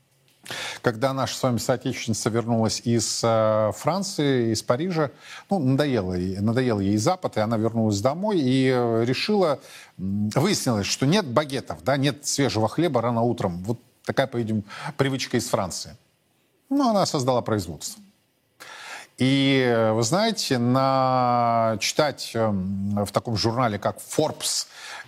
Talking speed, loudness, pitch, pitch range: 125 wpm, -23 LUFS, 125 Hz, 110-135 Hz